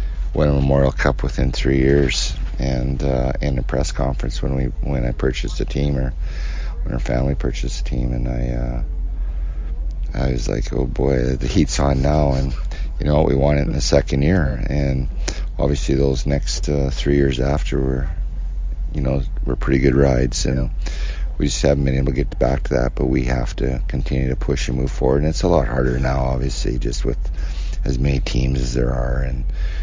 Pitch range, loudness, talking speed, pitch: 65-70 Hz, -20 LUFS, 205 wpm, 65 Hz